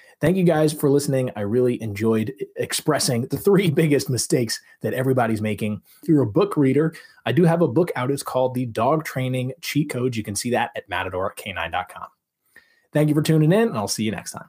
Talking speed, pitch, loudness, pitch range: 210 wpm, 135 Hz, -22 LUFS, 120-160 Hz